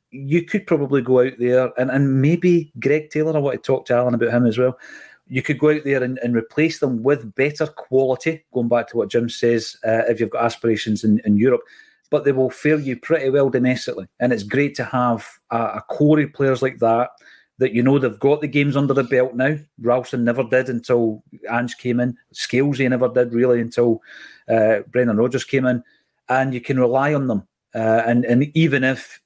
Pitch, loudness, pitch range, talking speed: 130 Hz, -19 LUFS, 120-140 Hz, 215 wpm